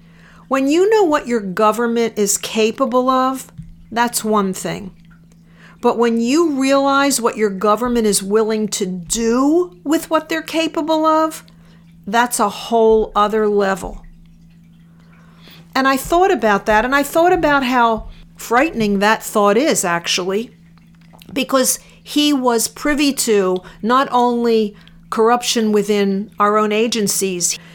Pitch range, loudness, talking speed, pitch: 185-260 Hz, -16 LUFS, 130 wpm, 220 Hz